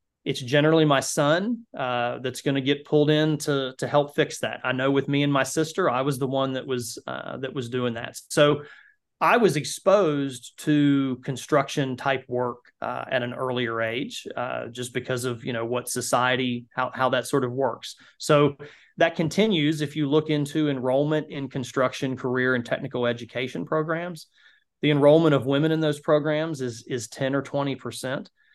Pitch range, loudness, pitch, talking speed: 125-150 Hz, -24 LUFS, 140 Hz, 185 wpm